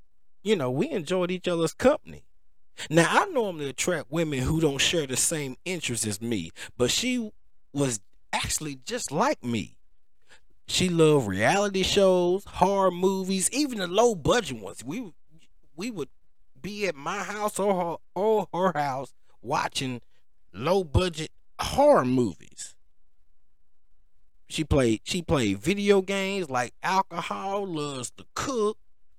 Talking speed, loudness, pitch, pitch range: 135 wpm, -26 LUFS, 165 Hz, 125-195 Hz